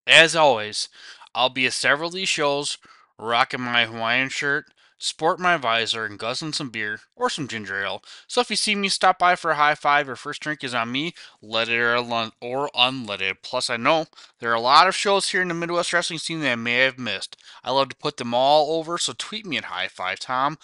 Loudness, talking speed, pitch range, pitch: -22 LUFS, 235 wpm, 120-165 Hz, 140 Hz